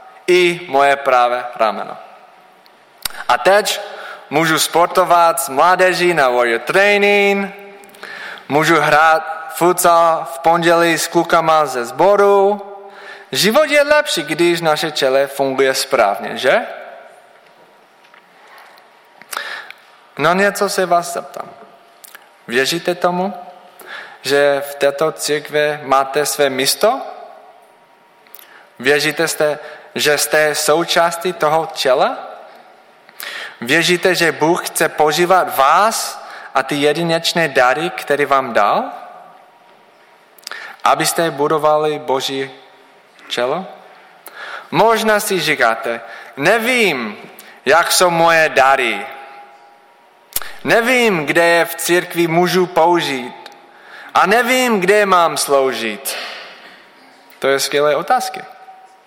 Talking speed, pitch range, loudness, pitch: 95 wpm, 145-185 Hz, -14 LUFS, 165 Hz